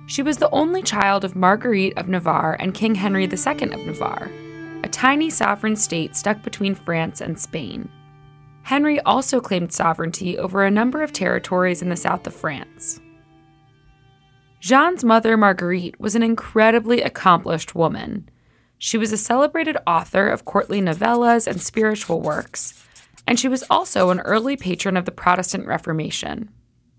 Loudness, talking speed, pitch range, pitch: -19 LUFS, 150 wpm, 165-230 Hz, 195 Hz